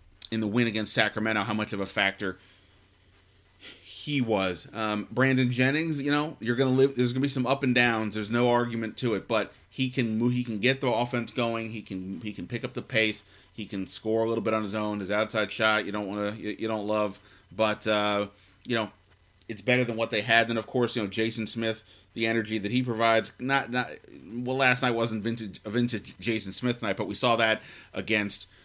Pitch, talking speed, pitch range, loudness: 110 Hz, 225 wpm, 105-120 Hz, -27 LUFS